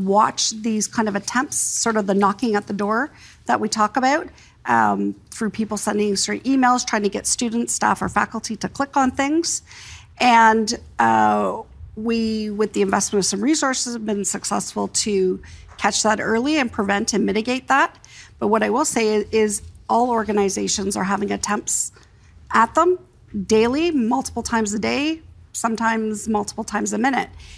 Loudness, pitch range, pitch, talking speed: -20 LUFS, 200-240 Hz, 220 Hz, 170 wpm